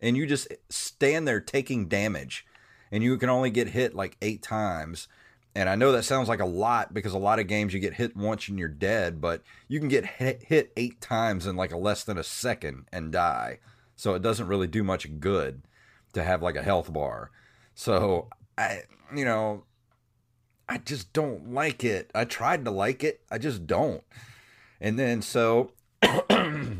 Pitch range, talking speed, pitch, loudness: 100-125 Hz, 195 wpm, 110 Hz, -28 LUFS